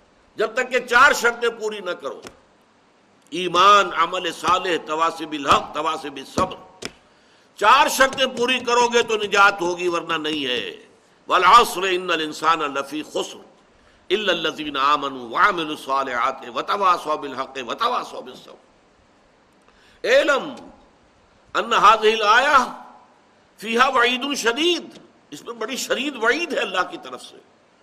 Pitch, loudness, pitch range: 210 Hz, -19 LUFS, 160-255 Hz